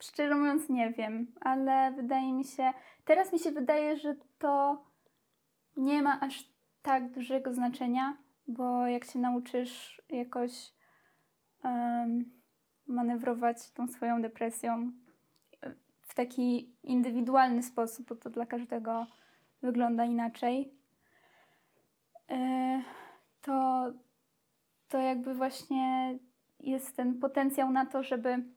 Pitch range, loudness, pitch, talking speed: 245-270 Hz, -33 LUFS, 255 Hz, 105 wpm